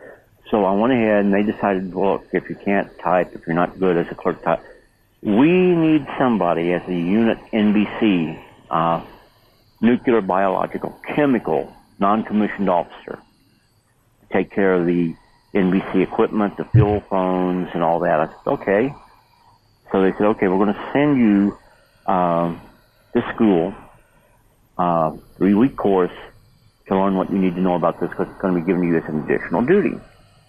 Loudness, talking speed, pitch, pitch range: -19 LUFS, 170 wpm, 95 Hz, 90-105 Hz